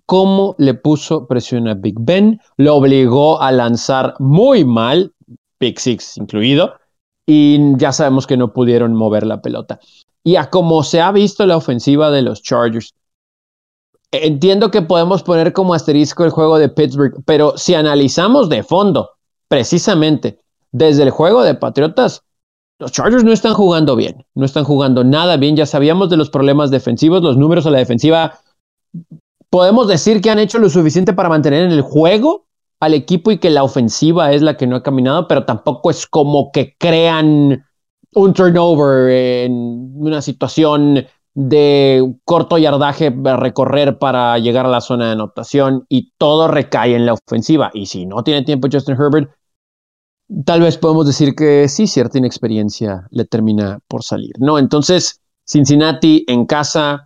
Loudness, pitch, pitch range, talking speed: -12 LUFS, 145 Hz, 130-165 Hz, 165 wpm